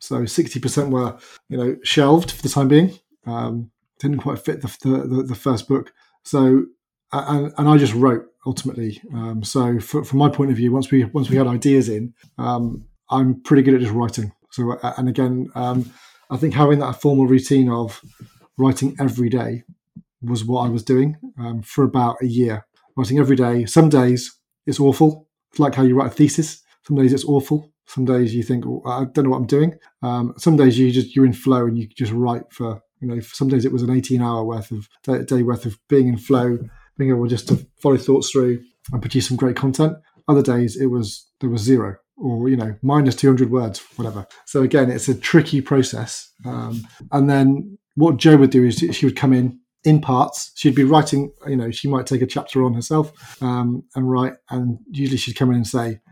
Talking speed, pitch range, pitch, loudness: 215 wpm, 120-140 Hz, 130 Hz, -18 LUFS